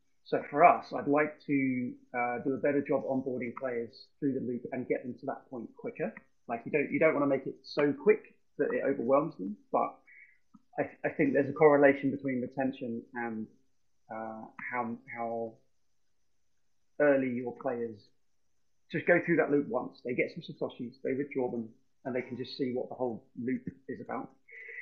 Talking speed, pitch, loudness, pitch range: 190 wpm, 130 Hz, -32 LUFS, 115-140 Hz